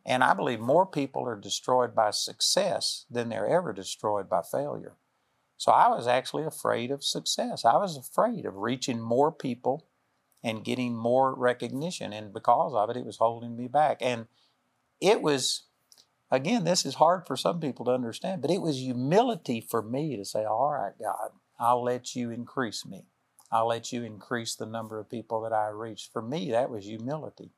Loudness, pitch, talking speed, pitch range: -28 LUFS, 120 Hz, 185 wpm, 115-130 Hz